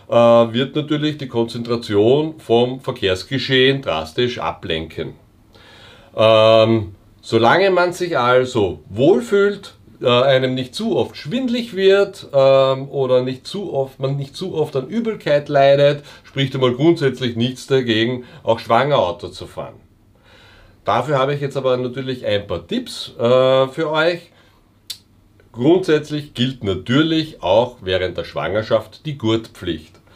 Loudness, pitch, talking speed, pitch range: -17 LUFS, 130 Hz, 125 wpm, 115-150 Hz